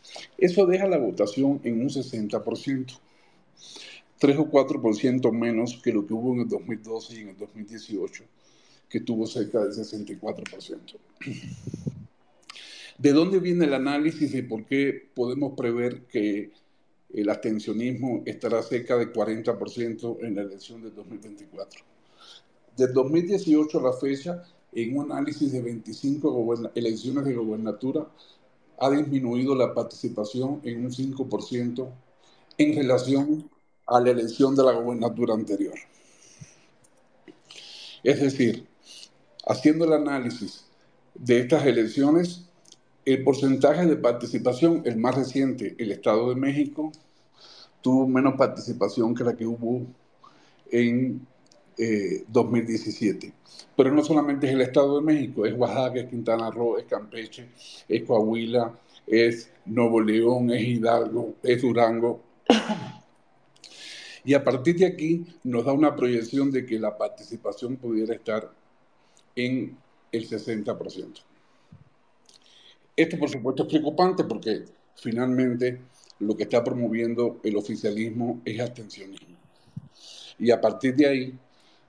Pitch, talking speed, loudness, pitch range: 125 Hz, 125 wpm, -25 LUFS, 115-140 Hz